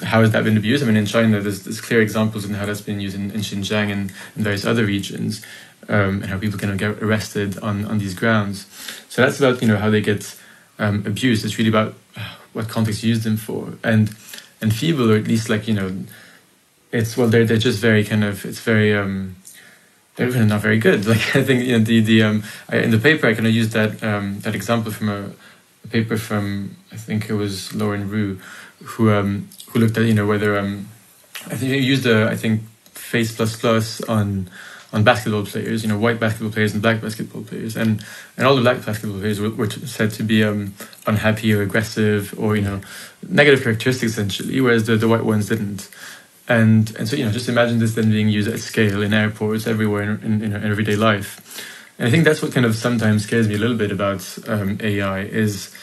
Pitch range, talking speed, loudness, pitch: 105-115 Hz, 230 wpm, -19 LUFS, 110 Hz